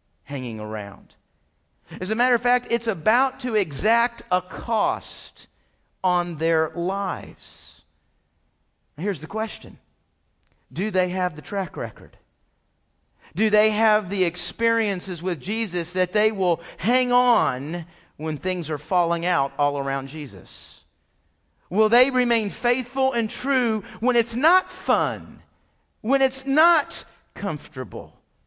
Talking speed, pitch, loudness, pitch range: 125 wpm, 185 Hz, -23 LUFS, 135-225 Hz